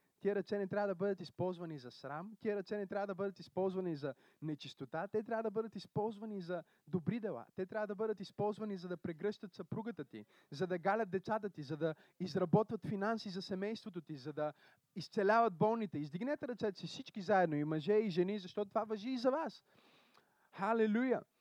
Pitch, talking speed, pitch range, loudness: 200 Hz, 190 wpm, 175-215 Hz, -39 LUFS